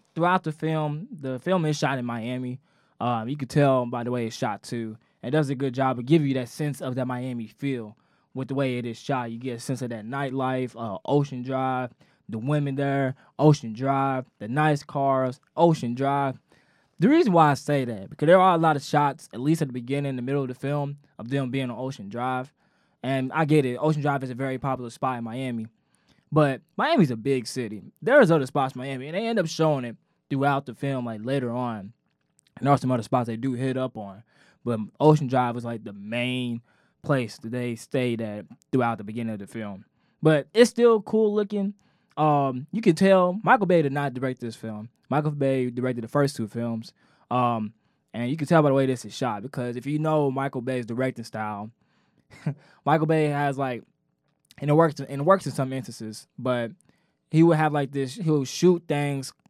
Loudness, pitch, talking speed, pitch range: -25 LUFS, 135 Hz, 220 wpm, 120-150 Hz